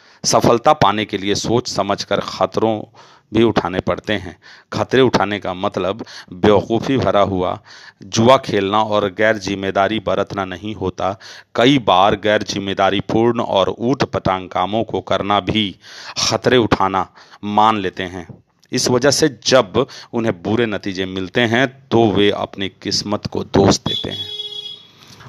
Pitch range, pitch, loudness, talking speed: 100-120 Hz, 105 Hz, -17 LUFS, 140 wpm